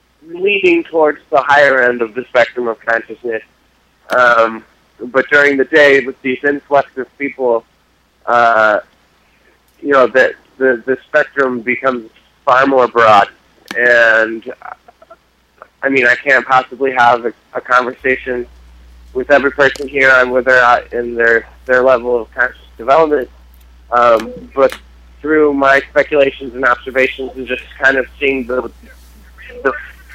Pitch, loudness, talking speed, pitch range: 130 Hz, -12 LUFS, 140 wpm, 115-135 Hz